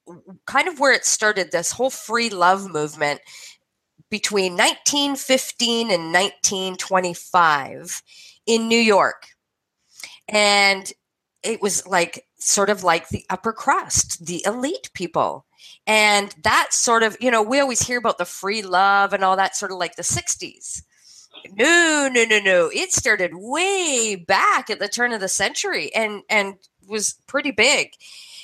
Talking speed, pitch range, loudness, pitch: 150 wpm, 185-235 Hz, -19 LUFS, 205 Hz